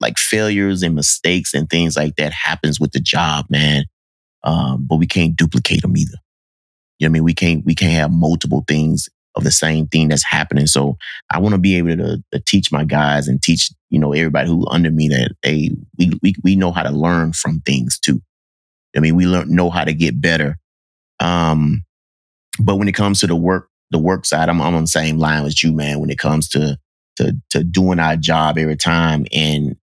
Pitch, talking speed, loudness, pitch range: 80 Hz, 225 wpm, -16 LUFS, 75-85 Hz